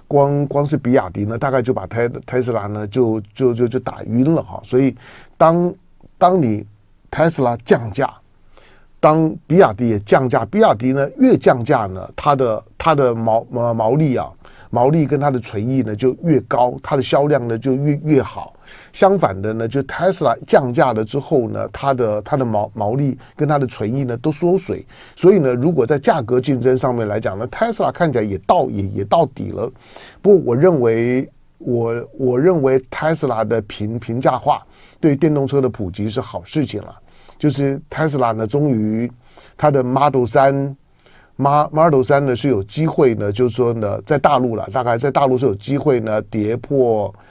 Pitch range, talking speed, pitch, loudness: 115-145 Hz, 280 characters per minute, 130 Hz, -17 LUFS